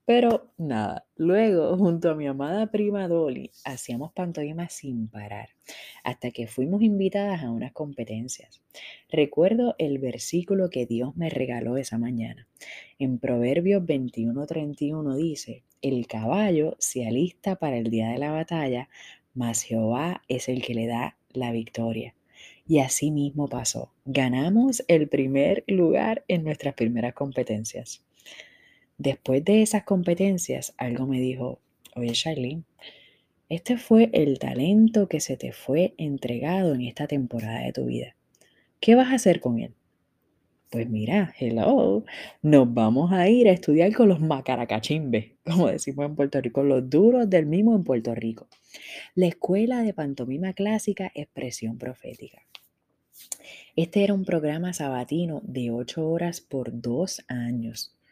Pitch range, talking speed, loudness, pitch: 125-180 Hz, 140 wpm, -25 LUFS, 145 Hz